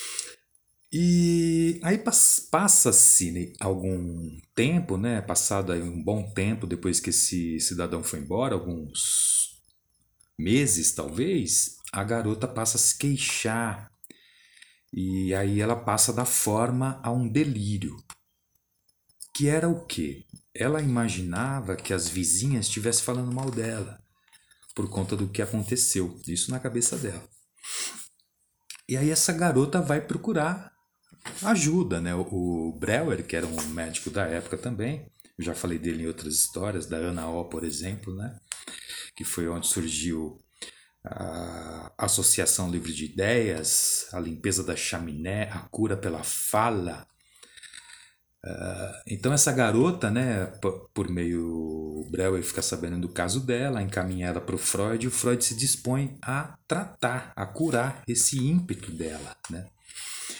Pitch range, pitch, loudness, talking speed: 90-125 Hz, 100 Hz, -25 LUFS, 135 wpm